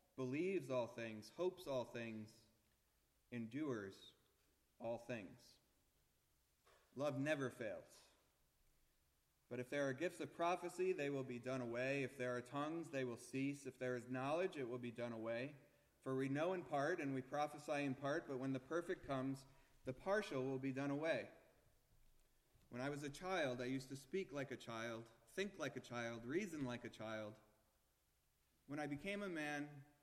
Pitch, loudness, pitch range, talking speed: 130 Hz, -46 LUFS, 115-145 Hz, 170 wpm